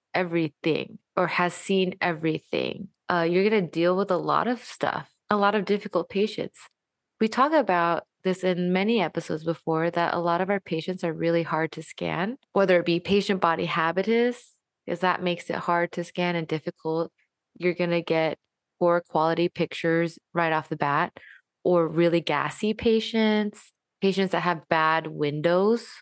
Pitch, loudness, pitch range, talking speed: 175 Hz, -25 LUFS, 165-195 Hz, 170 wpm